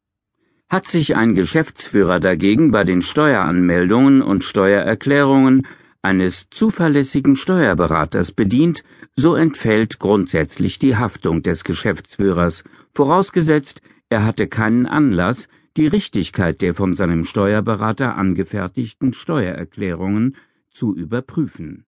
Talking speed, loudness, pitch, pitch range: 100 wpm, -17 LUFS, 110 Hz, 95-150 Hz